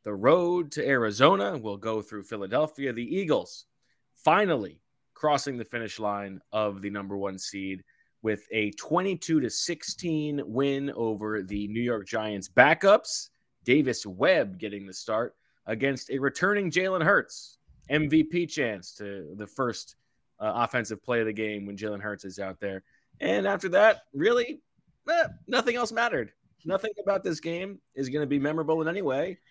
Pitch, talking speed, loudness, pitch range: 130 Hz, 160 wpm, -27 LUFS, 105-170 Hz